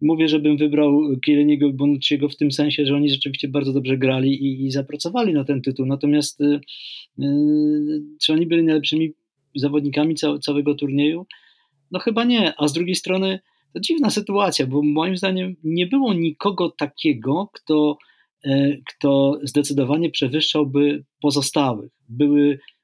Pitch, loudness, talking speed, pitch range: 150 Hz, -20 LUFS, 145 wpm, 140-160 Hz